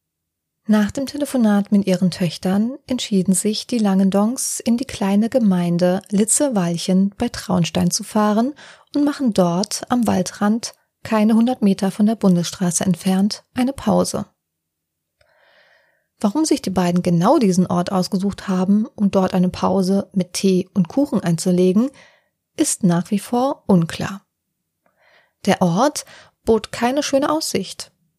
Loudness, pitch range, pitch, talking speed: -19 LUFS, 185-240 Hz, 200 Hz, 130 wpm